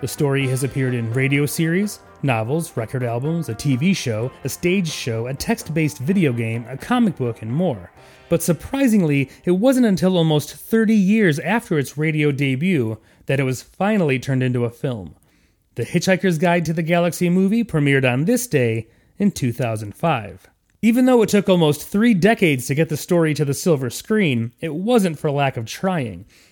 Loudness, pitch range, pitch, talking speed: -19 LUFS, 130-185 Hz, 155 Hz, 180 wpm